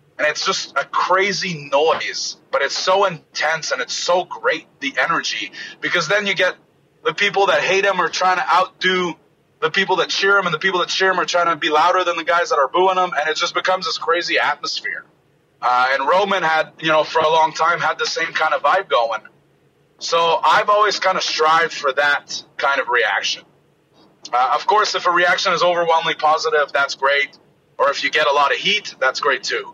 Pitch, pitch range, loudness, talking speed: 175 Hz, 155-190 Hz, -17 LUFS, 220 wpm